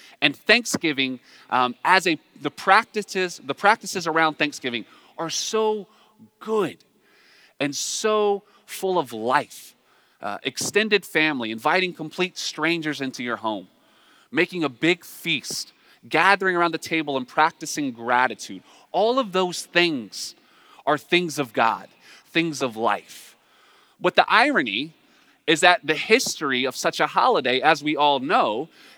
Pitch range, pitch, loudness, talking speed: 140-195 Hz, 160 Hz, -22 LUFS, 135 wpm